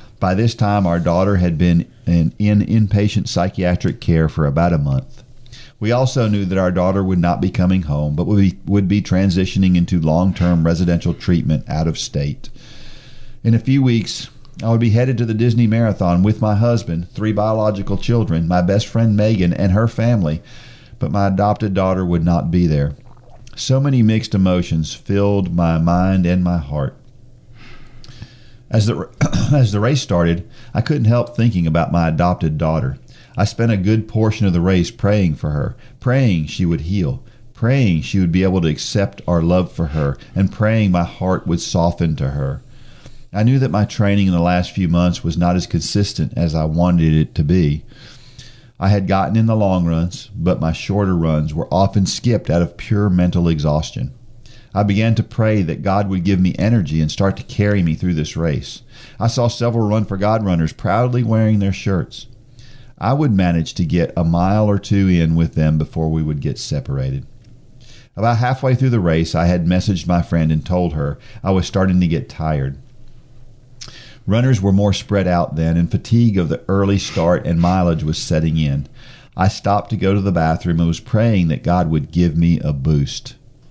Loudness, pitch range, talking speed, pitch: -17 LUFS, 85-115 Hz, 190 wpm, 100 Hz